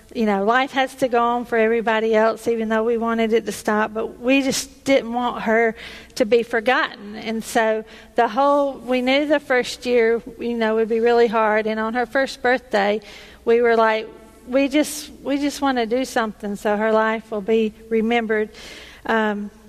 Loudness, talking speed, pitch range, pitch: -20 LUFS, 195 wpm, 220-255 Hz, 230 Hz